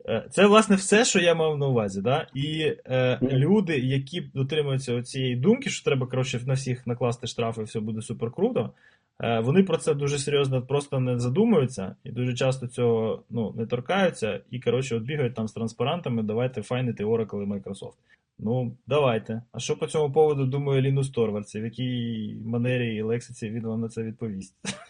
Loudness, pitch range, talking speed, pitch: -26 LUFS, 115-145 Hz, 180 wpm, 125 Hz